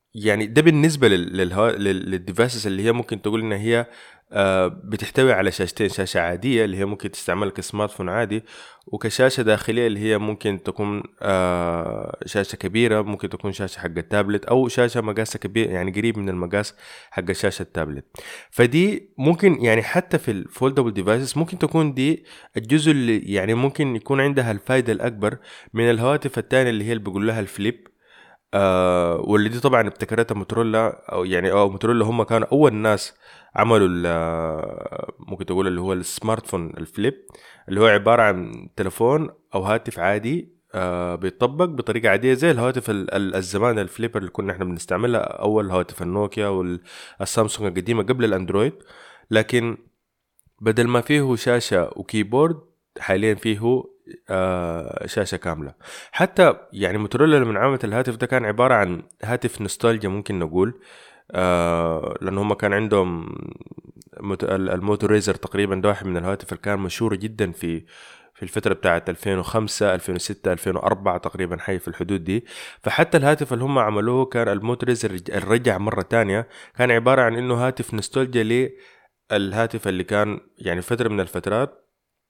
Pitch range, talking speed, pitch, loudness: 95-120 Hz, 145 wpm, 105 Hz, -21 LUFS